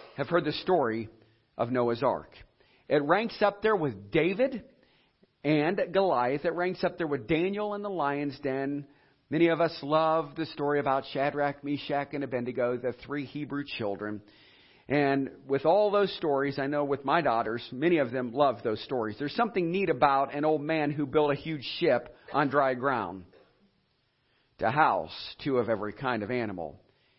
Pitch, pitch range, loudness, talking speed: 145 Hz, 130-160 Hz, -29 LUFS, 175 wpm